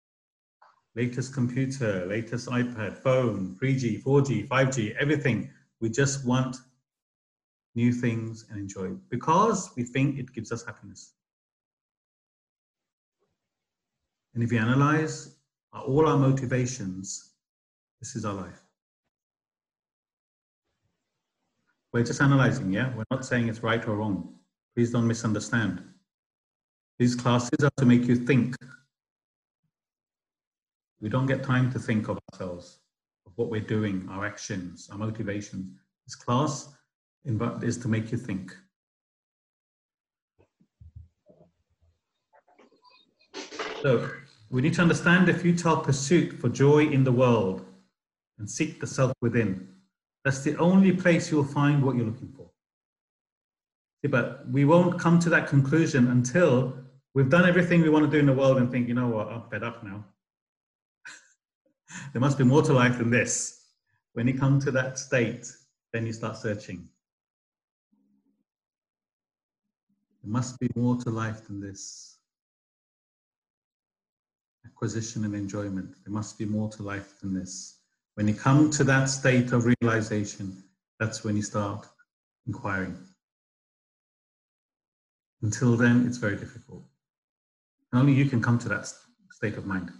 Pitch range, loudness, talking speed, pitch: 105-135 Hz, -26 LUFS, 135 wpm, 120 Hz